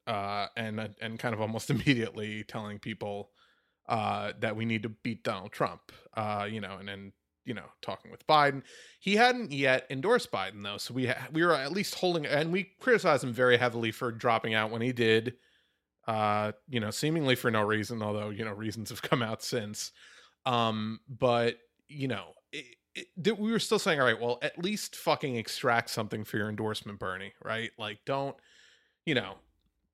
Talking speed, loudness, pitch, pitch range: 190 wpm, -31 LUFS, 115 Hz, 110-140 Hz